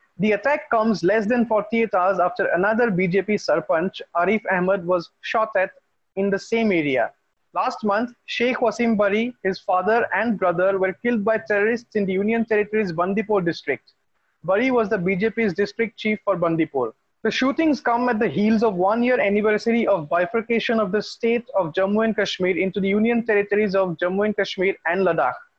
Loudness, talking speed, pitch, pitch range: -21 LUFS, 180 wpm, 210 Hz, 190-230 Hz